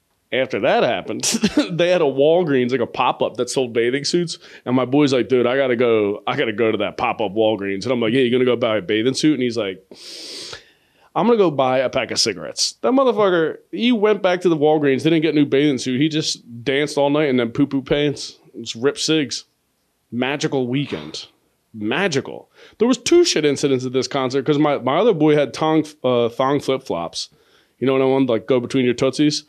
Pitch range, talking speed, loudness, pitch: 130-155 Hz, 230 wpm, -19 LUFS, 140 Hz